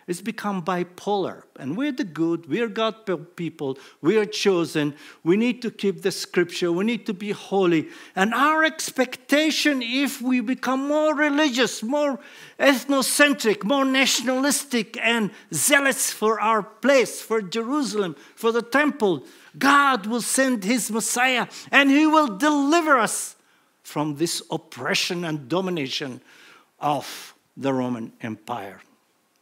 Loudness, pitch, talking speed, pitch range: -22 LUFS, 225 Hz, 135 wpm, 180-275 Hz